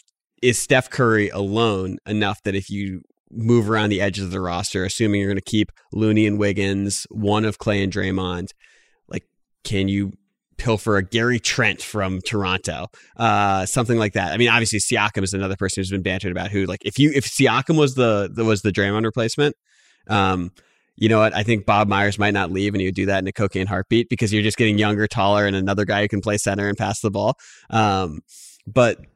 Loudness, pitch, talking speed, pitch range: -20 LUFS, 100 Hz, 215 wpm, 95-110 Hz